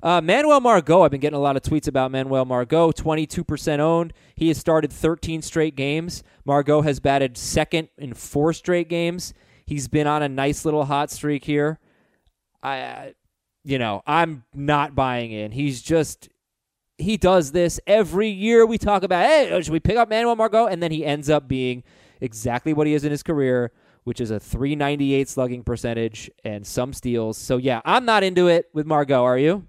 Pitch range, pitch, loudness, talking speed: 130-170 Hz, 150 Hz, -21 LUFS, 195 wpm